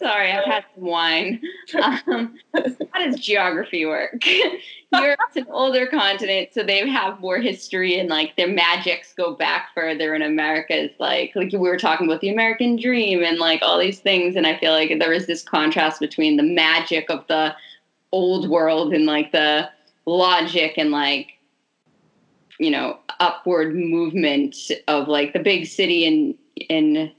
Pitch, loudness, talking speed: 185 Hz, -19 LUFS, 170 wpm